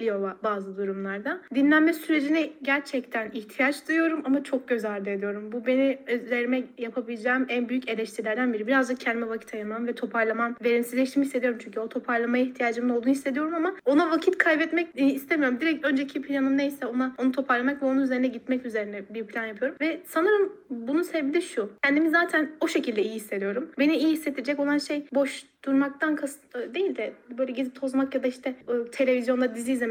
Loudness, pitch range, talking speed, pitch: -26 LUFS, 235-290 Hz, 170 wpm, 260 Hz